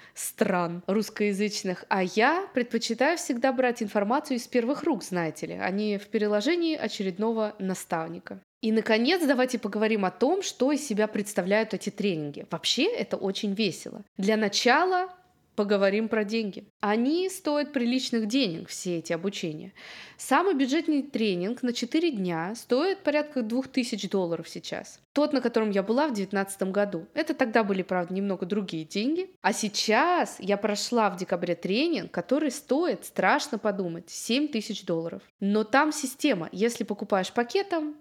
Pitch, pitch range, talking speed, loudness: 220 Hz, 195-270 Hz, 145 wpm, -27 LUFS